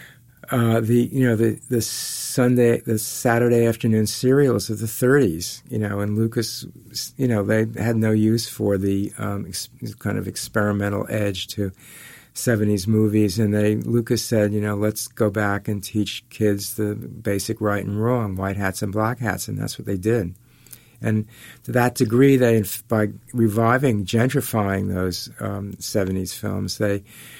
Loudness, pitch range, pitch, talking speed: -22 LUFS, 105-120 Hz, 110 Hz, 165 wpm